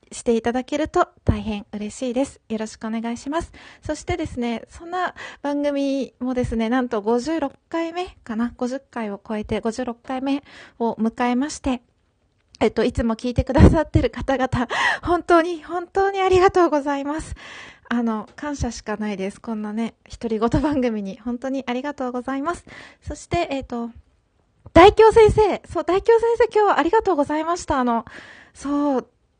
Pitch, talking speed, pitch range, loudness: 265 Hz, 330 characters per minute, 235-325 Hz, -21 LUFS